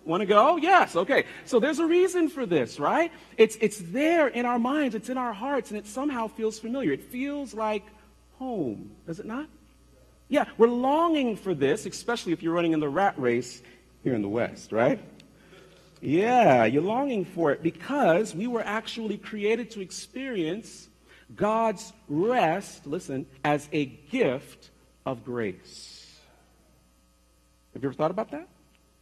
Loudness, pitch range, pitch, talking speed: -26 LUFS, 160-255 Hz, 215 Hz, 160 wpm